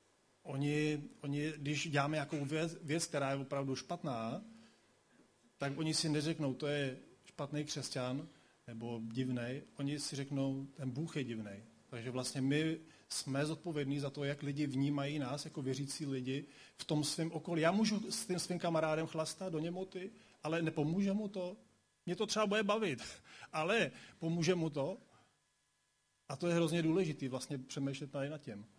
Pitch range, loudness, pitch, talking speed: 140-165 Hz, -38 LUFS, 150 Hz, 165 wpm